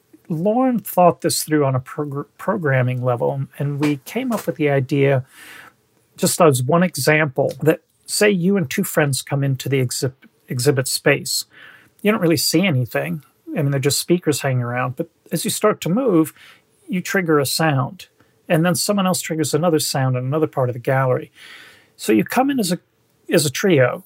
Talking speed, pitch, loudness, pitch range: 190 wpm, 155 Hz, -19 LUFS, 135-180 Hz